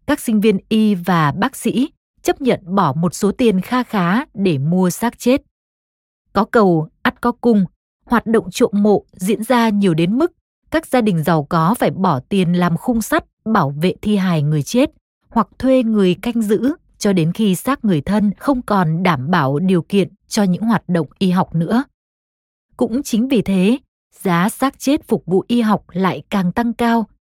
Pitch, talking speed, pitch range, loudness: 205 Hz, 195 wpm, 180-240 Hz, -17 LUFS